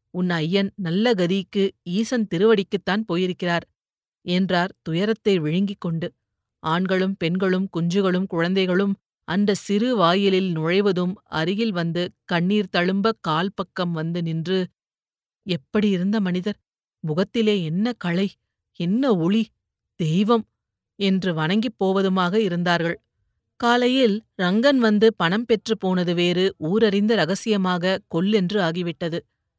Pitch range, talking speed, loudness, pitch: 170-205 Hz, 105 wpm, -22 LUFS, 185 Hz